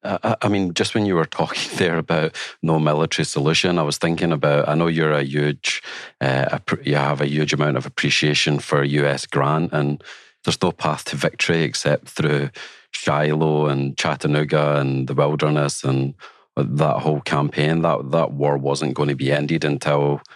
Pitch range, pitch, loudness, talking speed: 70-75 Hz, 75 Hz, -20 LUFS, 175 wpm